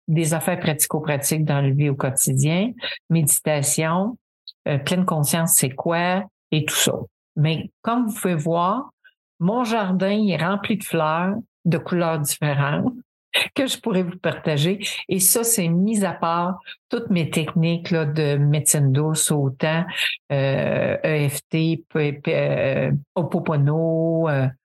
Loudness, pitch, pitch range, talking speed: -21 LUFS, 165 Hz, 150-185 Hz, 130 wpm